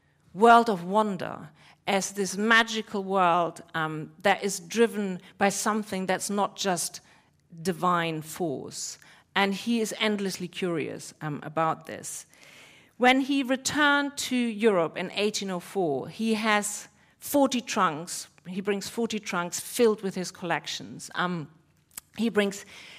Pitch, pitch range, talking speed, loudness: 195 Hz, 175-220 Hz, 125 wpm, -27 LUFS